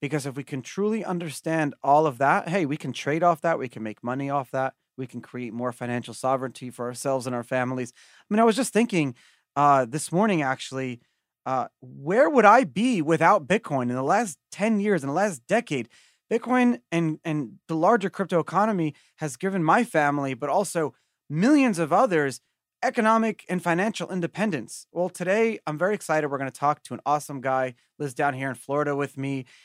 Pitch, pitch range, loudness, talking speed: 150 Hz, 135-190 Hz, -25 LUFS, 200 wpm